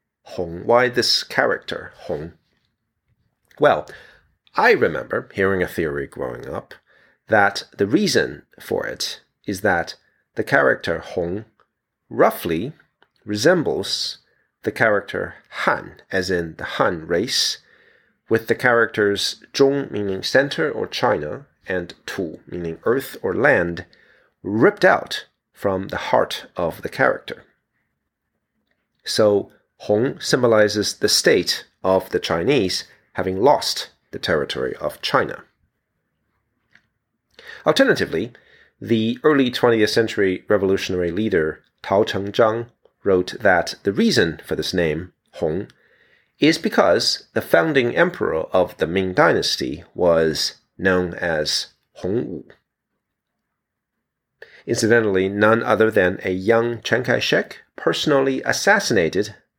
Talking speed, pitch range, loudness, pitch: 115 wpm, 95-125 Hz, -20 LUFS, 110 Hz